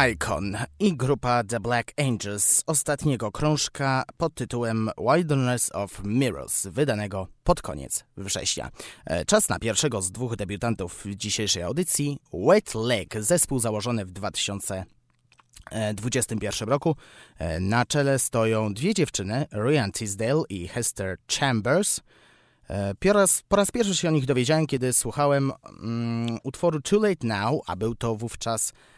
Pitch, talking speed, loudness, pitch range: 115 Hz, 130 wpm, -25 LUFS, 105-145 Hz